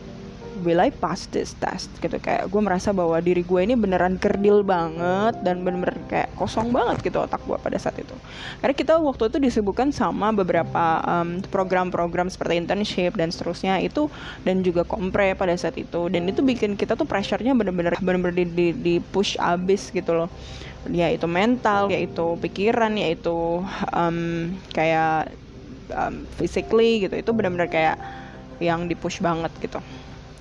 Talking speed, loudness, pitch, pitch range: 160 wpm, -23 LUFS, 180 Hz, 170-205 Hz